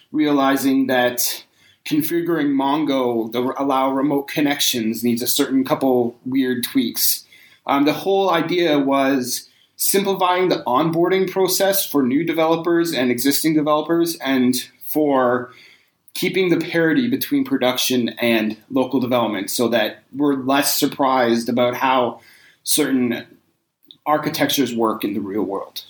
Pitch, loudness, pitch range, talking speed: 140 Hz, -19 LUFS, 125-165 Hz, 125 wpm